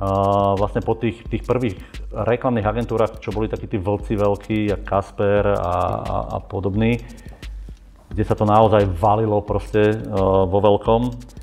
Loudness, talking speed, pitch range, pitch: -20 LUFS, 150 wpm, 100-110 Hz, 105 Hz